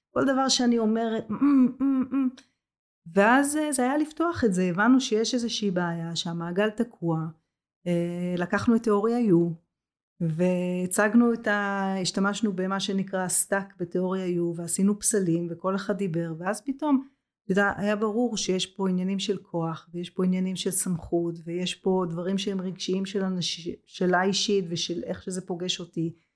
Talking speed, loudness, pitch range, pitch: 135 wpm, -26 LUFS, 175-220 Hz, 195 Hz